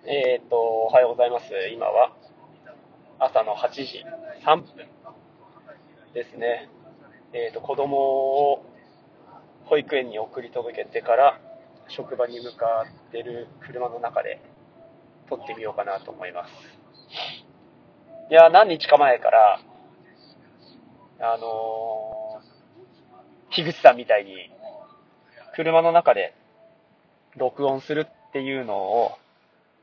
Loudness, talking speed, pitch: -22 LUFS, 195 characters per minute, 140 Hz